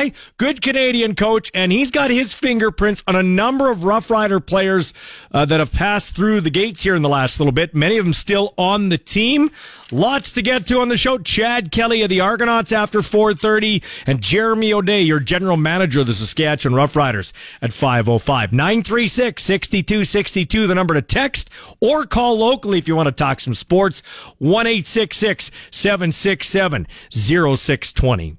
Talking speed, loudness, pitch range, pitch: 165 wpm, -16 LUFS, 155-225 Hz, 195 Hz